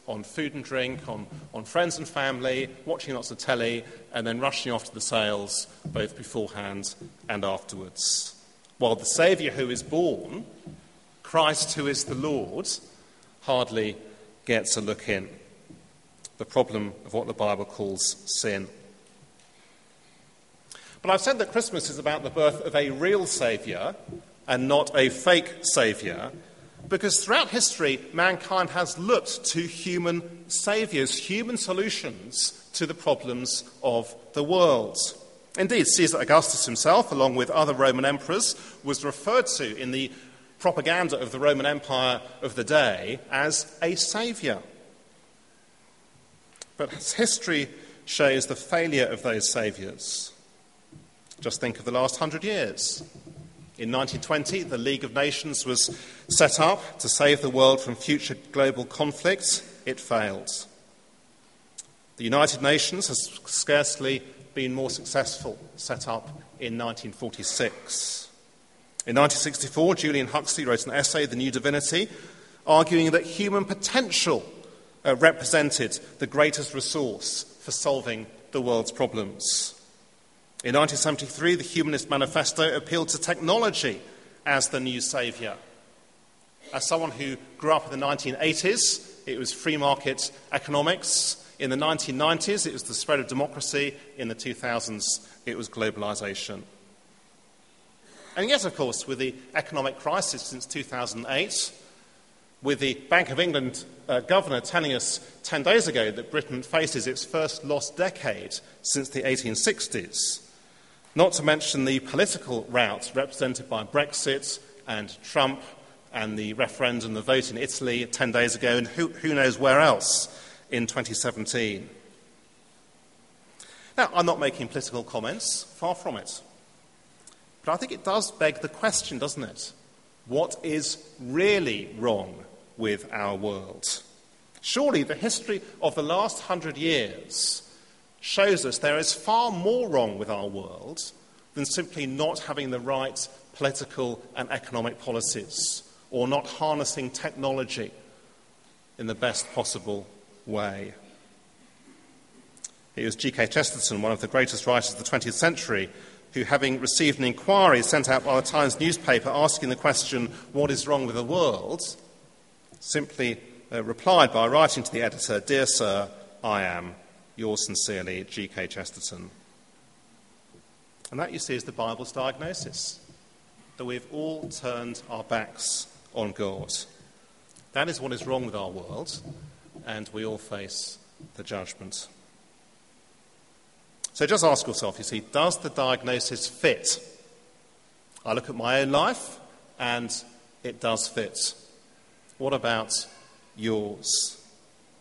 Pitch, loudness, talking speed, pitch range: 140 Hz, -26 LUFS, 135 wpm, 120-160 Hz